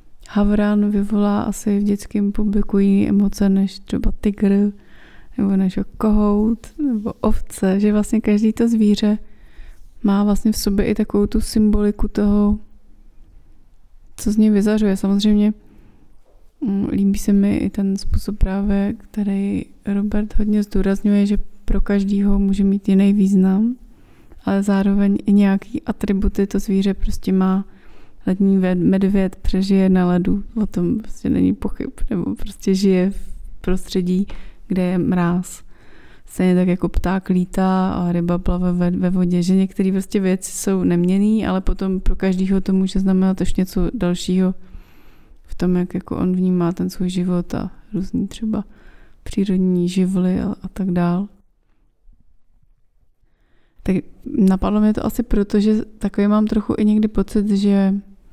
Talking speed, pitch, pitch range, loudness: 140 wpm, 200 Hz, 190-210 Hz, -19 LUFS